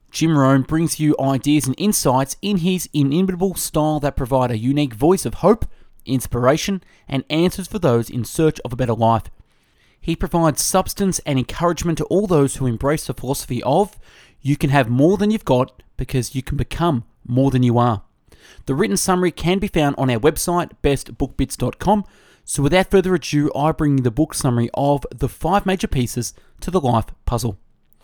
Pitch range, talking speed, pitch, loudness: 130-170 Hz, 185 wpm, 145 Hz, -19 LUFS